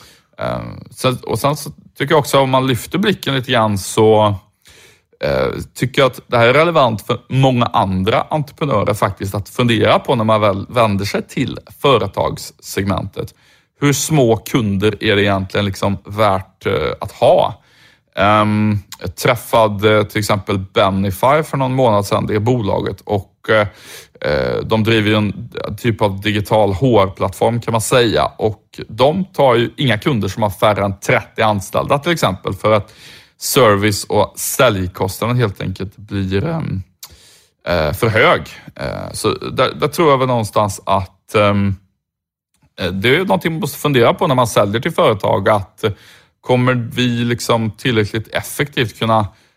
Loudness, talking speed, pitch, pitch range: -16 LUFS, 150 wpm, 110 Hz, 100-125 Hz